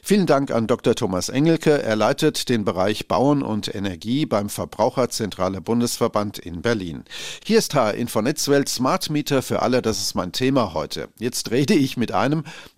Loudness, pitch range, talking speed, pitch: -21 LUFS, 105-145 Hz, 180 wpm, 120 Hz